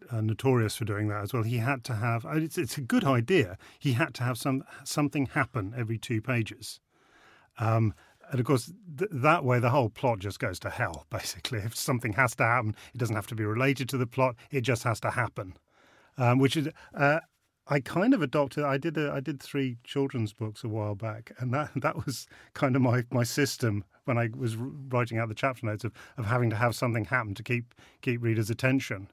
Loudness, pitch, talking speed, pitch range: -29 LUFS, 125 Hz, 225 wpm, 115-135 Hz